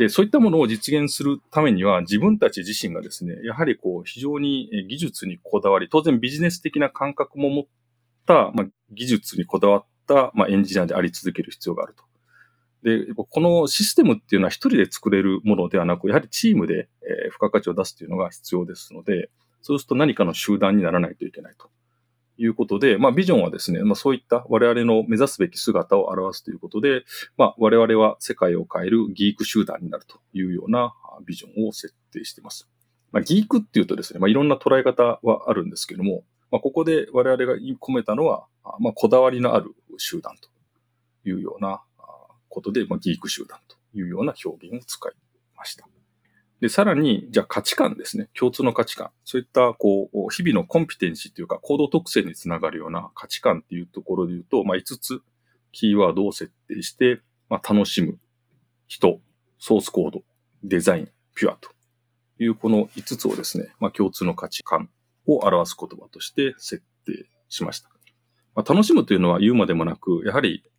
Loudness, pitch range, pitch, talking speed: -21 LUFS, 110-140 Hz, 120 Hz, 400 characters per minute